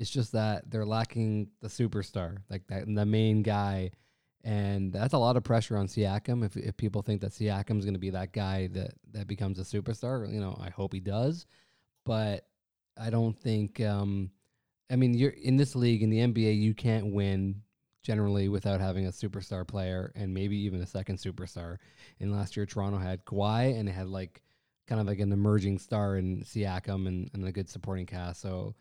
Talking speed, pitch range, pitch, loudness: 200 wpm, 95-110 Hz, 105 Hz, -32 LUFS